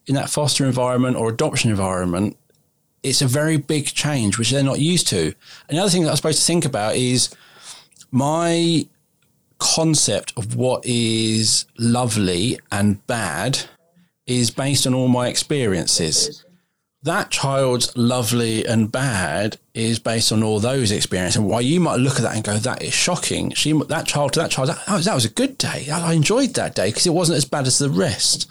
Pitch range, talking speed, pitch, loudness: 115-155 Hz, 185 wpm, 135 Hz, -19 LUFS